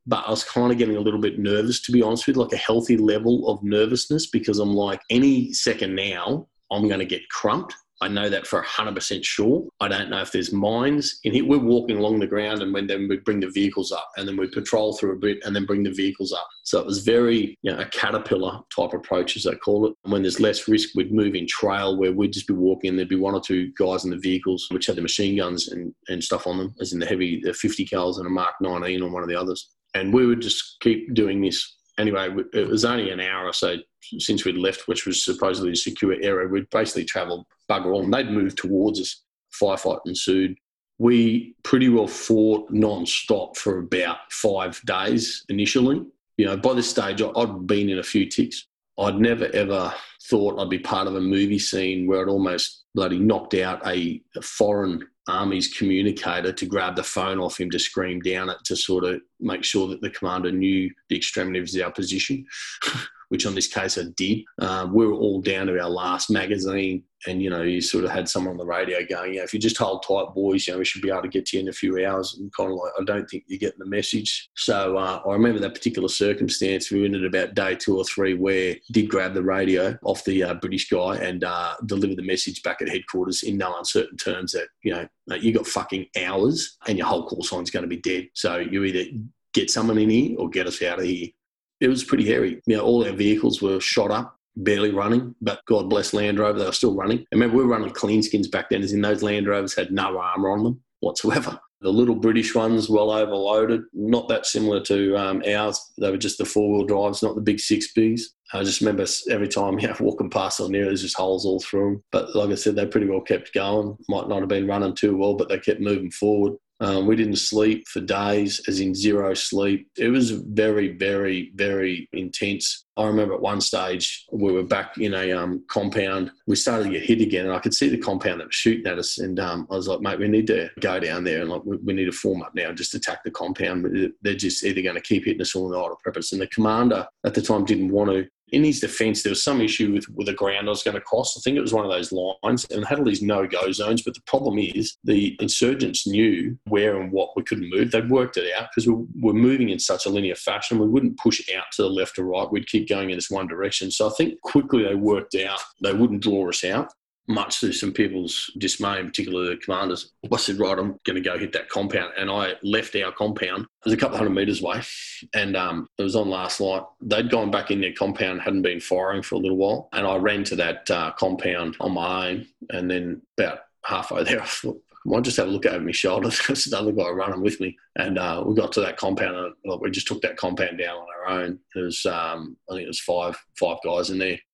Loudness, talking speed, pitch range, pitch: -23 LUFS, 245 wpm, 95-110 Hz, 100 Hz